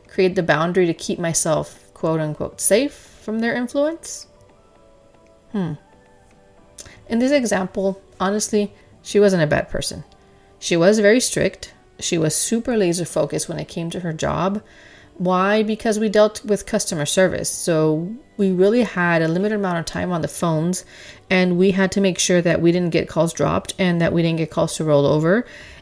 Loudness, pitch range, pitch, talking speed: -19 LUFS, 160-205 Hz, 180 Hz, 180 wpm